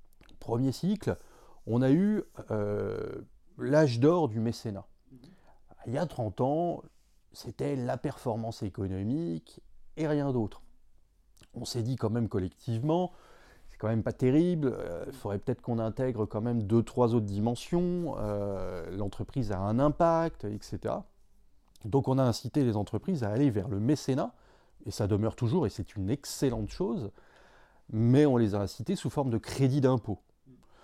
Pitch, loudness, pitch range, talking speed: 120 Hz, -30 LUFS, 105-140 Hz, 160 wpm